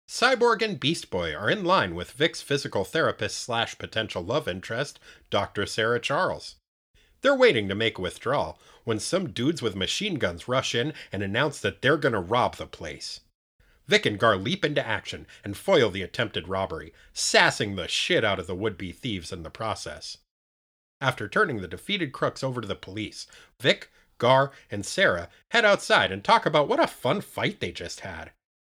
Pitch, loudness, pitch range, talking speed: 115 Hz, -25 LUFS, 95-140 Hz, 185 wpm